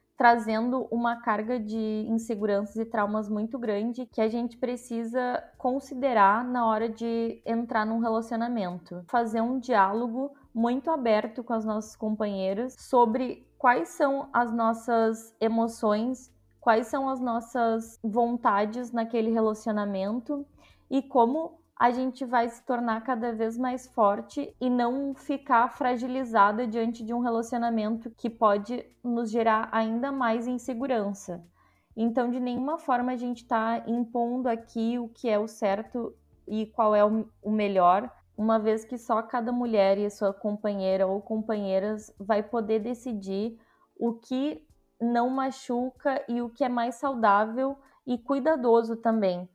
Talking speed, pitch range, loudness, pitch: 140 wpm, 220-250 Hz, -28 LUFS, 230 Hz